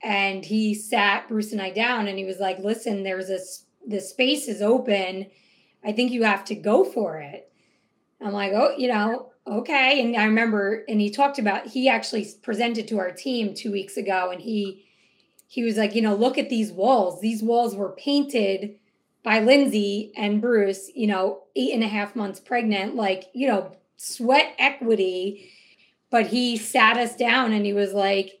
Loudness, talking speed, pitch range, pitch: -23 LUFS, 190 wpm, 200-240 Hz, 215 Hz